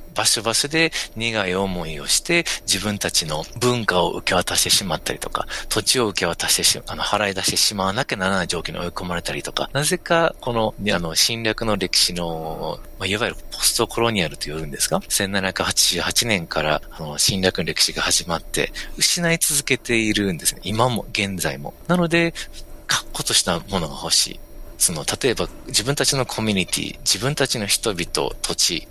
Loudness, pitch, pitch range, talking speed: -20 LUFS, 105 Hz, 90-130 Hz, 370 characters per minute